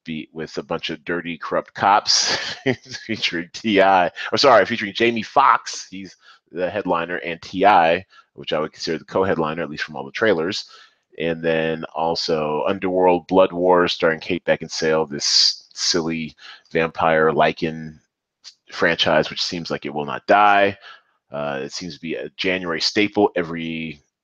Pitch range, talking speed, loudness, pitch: 80-95 Hz, 155 wpm, -20 LUFS, 85 Hz